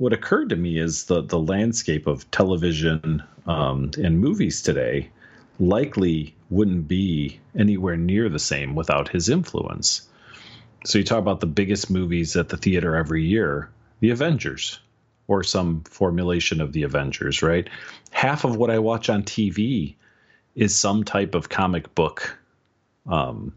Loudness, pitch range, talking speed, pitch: -22 LUFS, 85-110 Hz, 150 wpm, 95 Hz